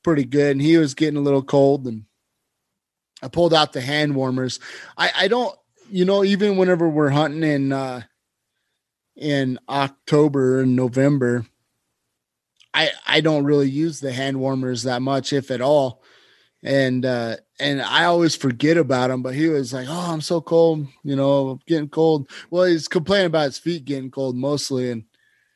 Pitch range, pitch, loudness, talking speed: 130-160 Hz, 140 Hz, -20 LUFS, 175 wpm